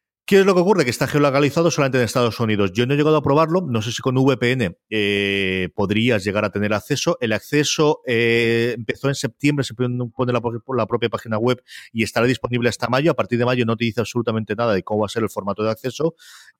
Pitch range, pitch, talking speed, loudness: 110-140 Hz, 120 Hz, 235 wpm, -20 LUFS